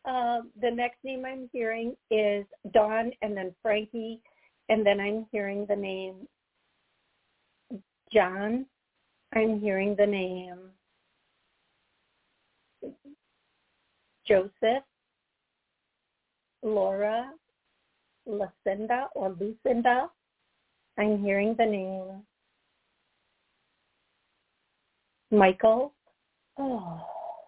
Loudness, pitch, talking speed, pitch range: -28 LUFS, 220 Hz, 70 wpm, 200-245 Hz